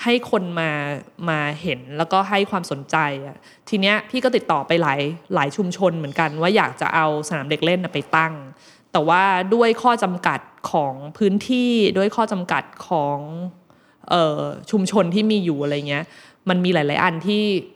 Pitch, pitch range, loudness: 175 Hz, 150-200 Hz, -20 LUFS